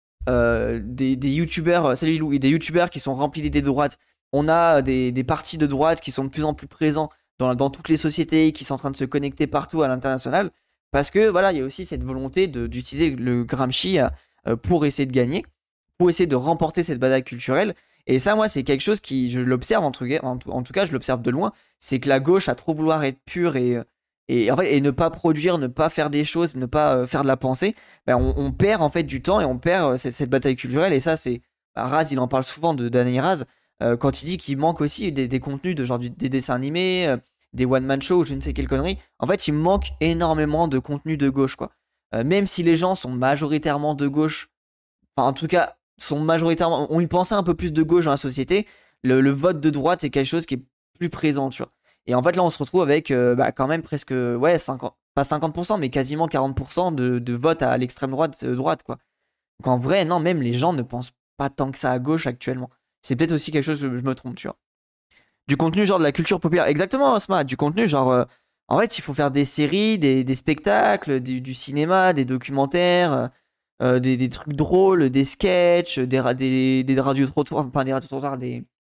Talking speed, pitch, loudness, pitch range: 235 wpm, 140 Hz, -21 LUFS, 130-165 Hz